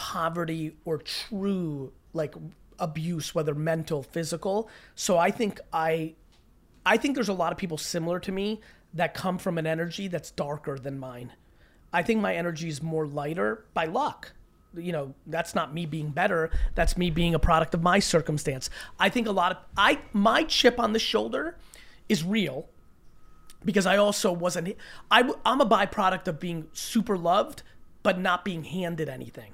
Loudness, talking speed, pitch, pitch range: -27 LUFS, 175 wpm, 170 Hz, 160-195 Hz